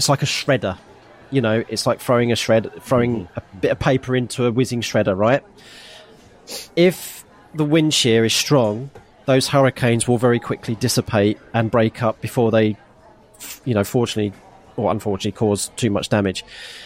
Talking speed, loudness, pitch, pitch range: 165 wpm, -19 LUFS, 120 Hz, 110-130 Hz